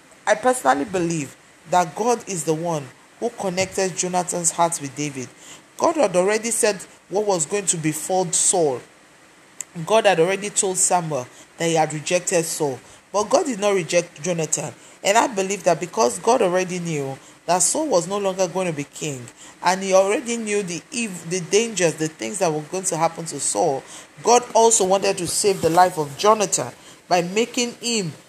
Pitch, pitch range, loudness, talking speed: 180 Hz, 165-205 Hz, -21 LUFS, 180 wpm